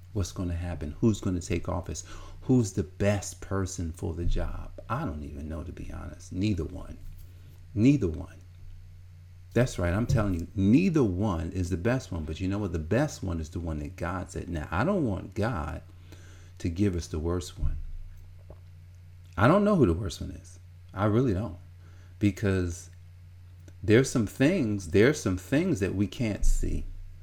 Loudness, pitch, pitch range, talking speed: -29 LUFS, 90 Hz, 85-100 Hz, 185 wpm